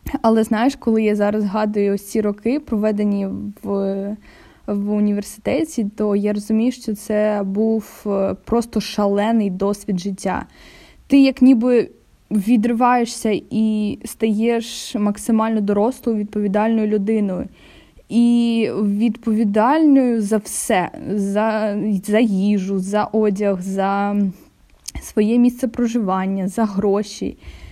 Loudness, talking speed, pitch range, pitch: -19 LUFS, 100 wpm, 205-230 Hz, 215 Hz